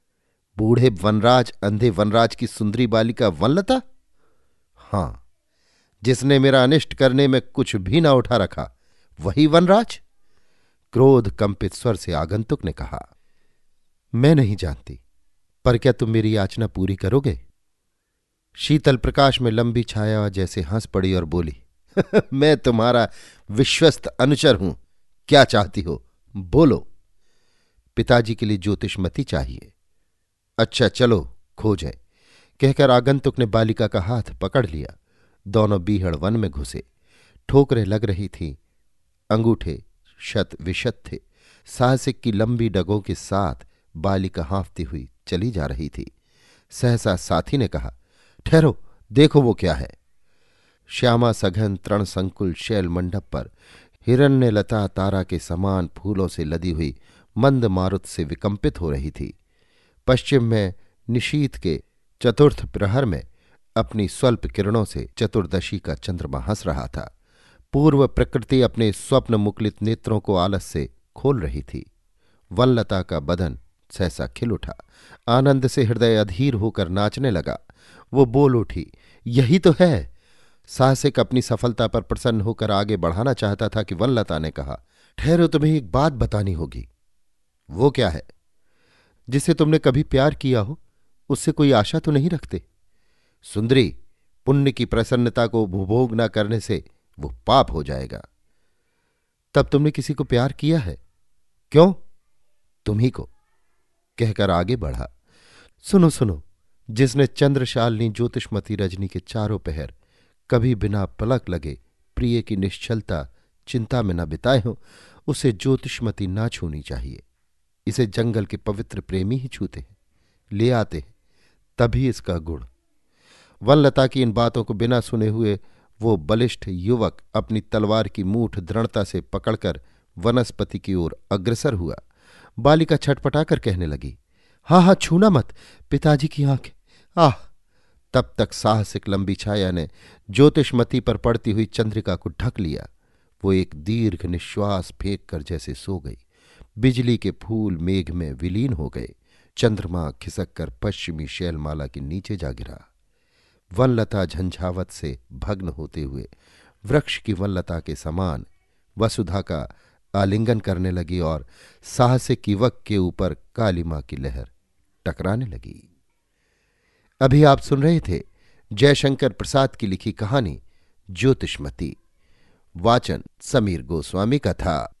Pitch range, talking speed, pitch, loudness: 90-125 Hz, 135 wpm, 105 Hz, -21 LUFS